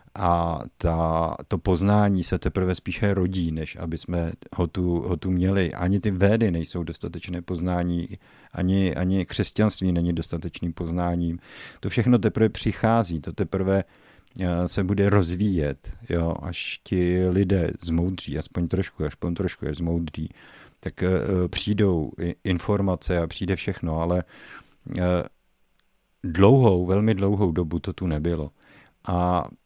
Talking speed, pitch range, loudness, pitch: 135 wpm, 85-95 Hz, -24 LUFS, 90 Hz